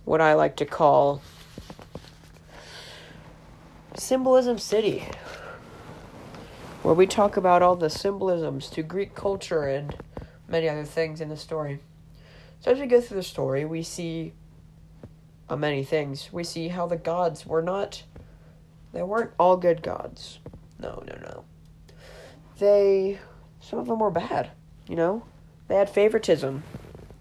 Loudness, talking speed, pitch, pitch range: -25 LUFS, 135 wpm, 165 Hz, 155-195 Hz